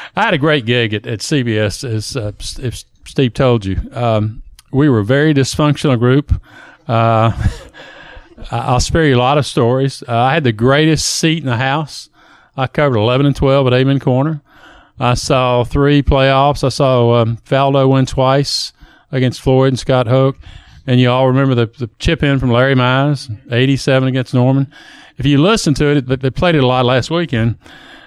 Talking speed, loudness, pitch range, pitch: 185 wpm, -14 LUFS, 120-140 Hz, 130 Hz